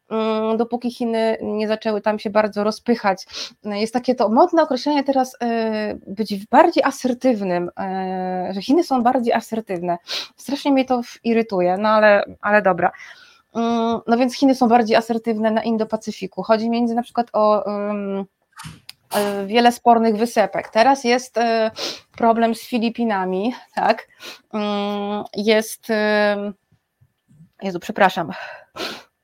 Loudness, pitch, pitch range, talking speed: -20 LUFS, 225 Hz, 205-240 Hz, 115 wpm